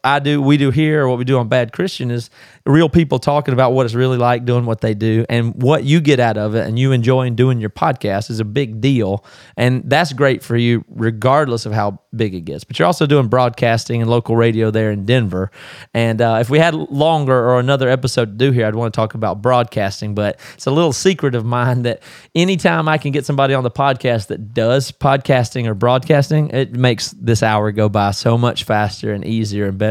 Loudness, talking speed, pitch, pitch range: -16 LUFS, 235 wpm, 125 Hz, 110-135 Hz